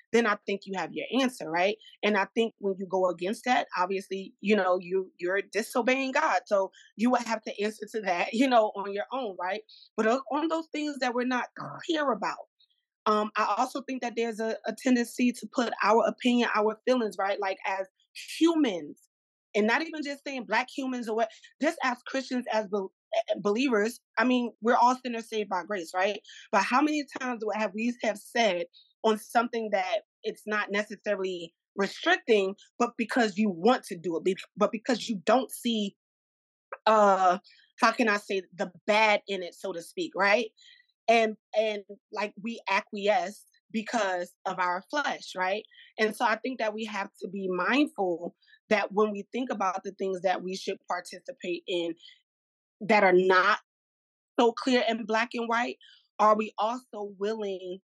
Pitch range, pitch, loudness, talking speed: 195-245 Hz, 215 Hz, -28 LUFS, 180 wpm